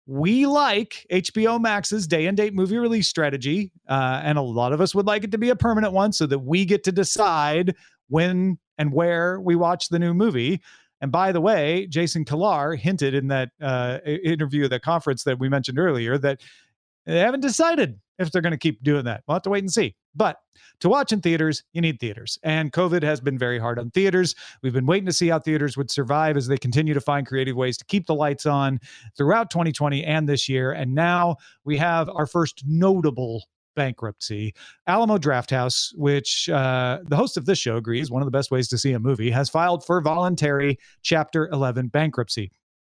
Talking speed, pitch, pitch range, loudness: 210 wpm, 150 Hz, 135-180 Hz, -22 LUFS